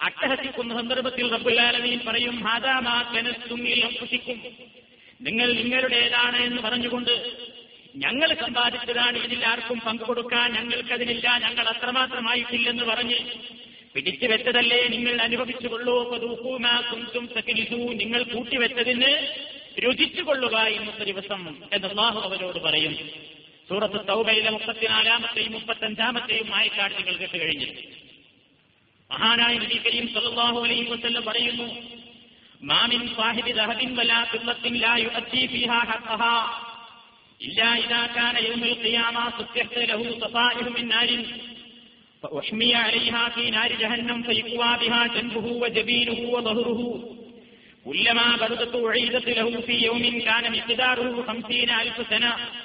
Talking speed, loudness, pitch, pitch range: 100 wpm, -23 LUFS, 235 Hz, 230-240 Hz